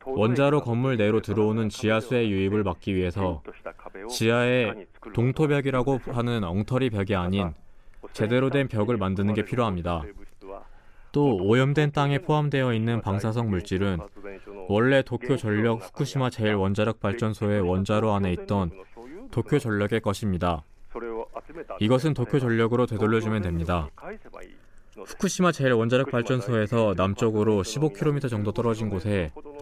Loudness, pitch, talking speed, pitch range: -25 LUFS, 110 Hz, 310 characters per minute, 100-125 Hz